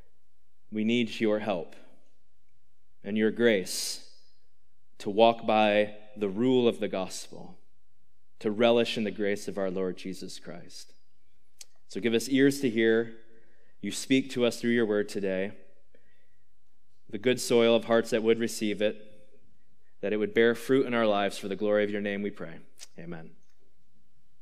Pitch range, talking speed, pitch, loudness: 105-115 Hz, 160 wpm, 110 Hz, -27 LUFS